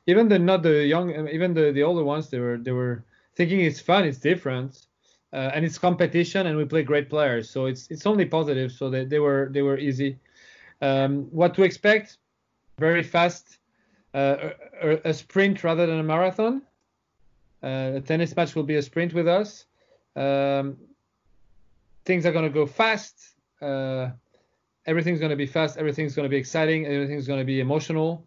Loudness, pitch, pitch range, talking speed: -24 LUFS, 155 Hz, 140-170 Hz, 180 wpm